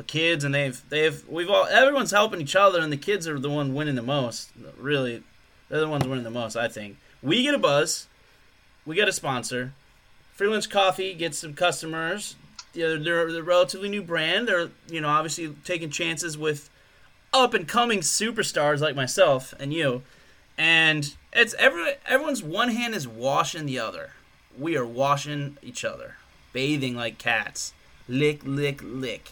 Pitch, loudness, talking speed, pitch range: 155 Hz, -24 LUFS, 170 wpm, 140-190 Hz